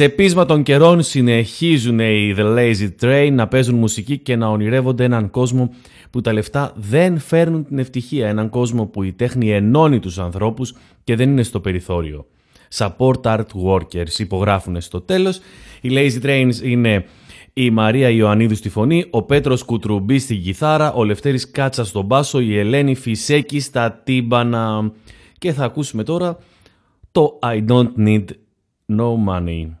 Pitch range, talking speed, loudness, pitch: 105-135 Hz, 155 wpm, -17 LUFS, 120 Hz